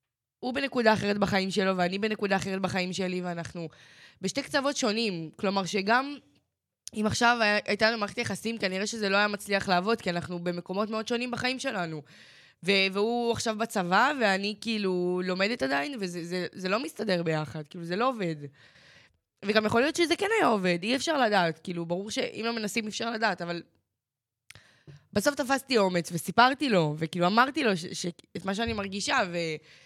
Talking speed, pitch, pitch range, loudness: 175 wpm, 195 Hz, 175-225 Hz, -28 LUFS